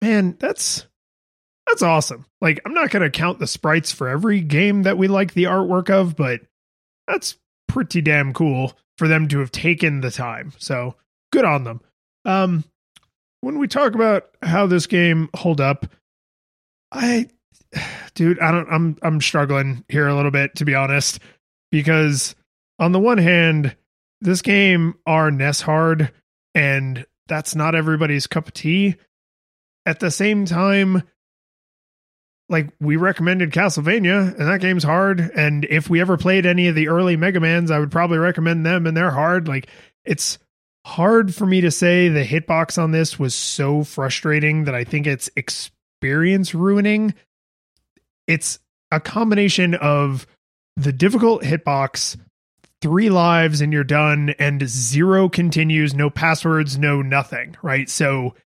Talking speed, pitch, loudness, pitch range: 155 wpm, 160 Hz, -18 LUFS, 145-180 Hz